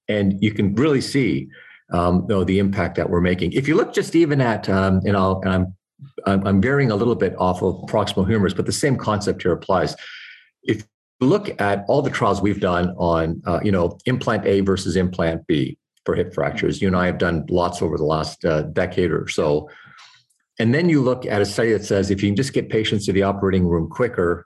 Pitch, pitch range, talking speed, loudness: 95 Hz, 90-105 Hz, 230 wpm, -20 LUFS